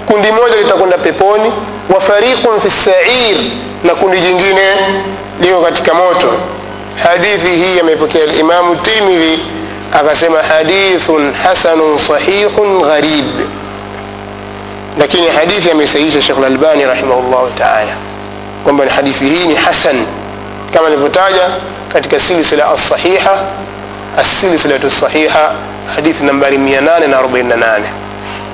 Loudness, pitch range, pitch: -9 LUFS, 125-185 Hz, 160 Hz